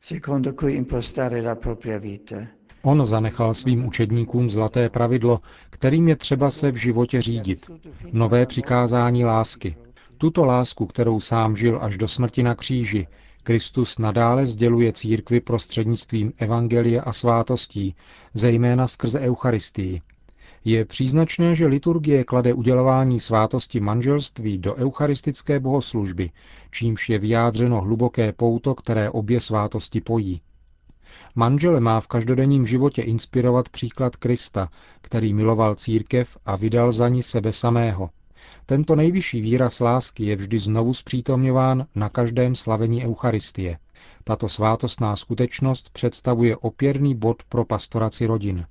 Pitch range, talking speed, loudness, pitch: 110-125 Hz, 115 wpm, -21 LUFS, 120 Hz